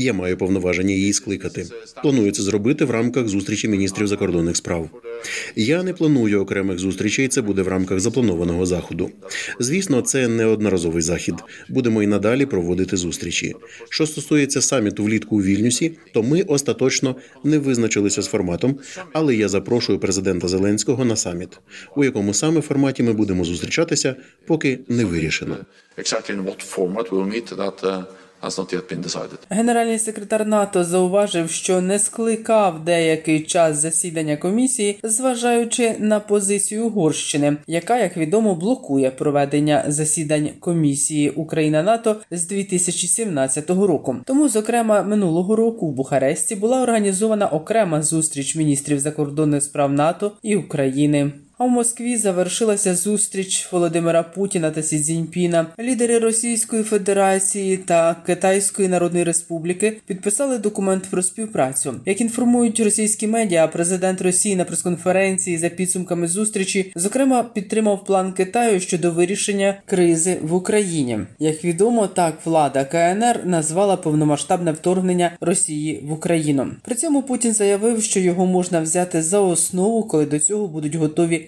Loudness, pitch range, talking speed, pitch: -19 LUFS, 135-200 Hz, 130 wpm, 165 Hz